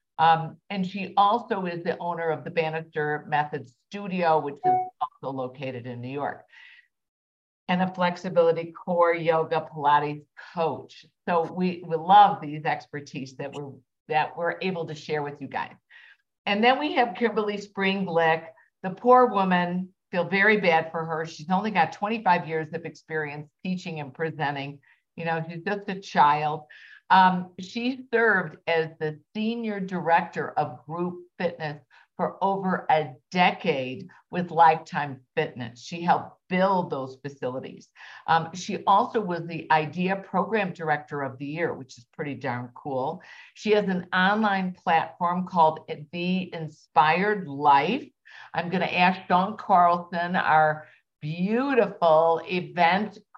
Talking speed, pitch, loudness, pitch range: 145 wpm, 170 Hz, -25 LUFS, 155-190 Hz